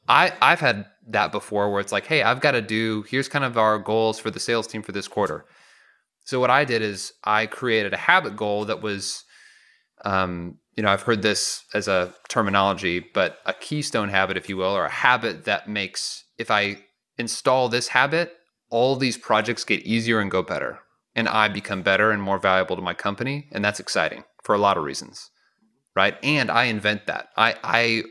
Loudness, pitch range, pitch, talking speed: -22 LUFS, 100-120 Hz, 110 Hz, 205 wpm